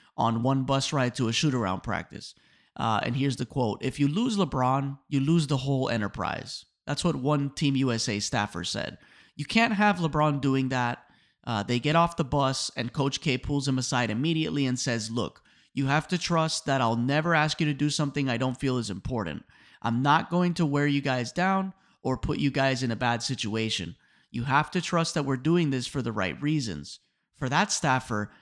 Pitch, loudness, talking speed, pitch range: 135 Hz, -27 LUFS, 210 wpm, 120-150 Hz